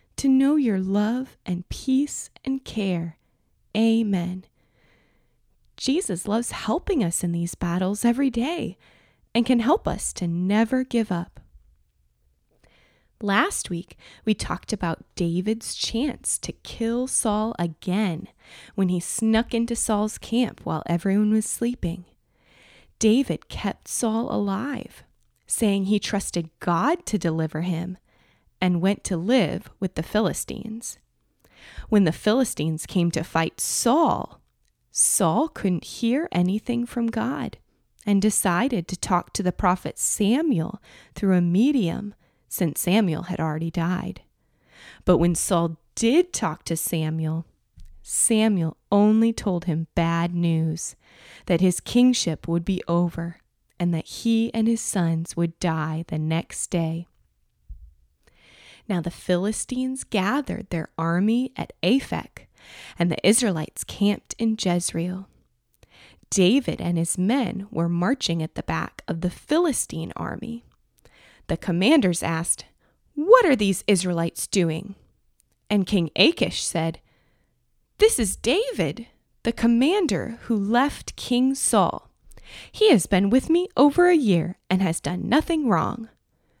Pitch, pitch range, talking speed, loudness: 195 Hz, 170-230 Hz, 130 wpm, -23 LUFS